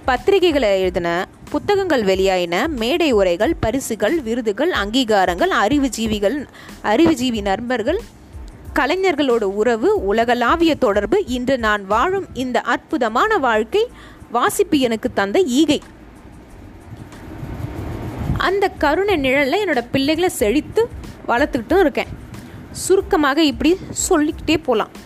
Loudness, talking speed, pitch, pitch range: -18 LUFS, 90 wpm, 270 Hz, 210-335 Hz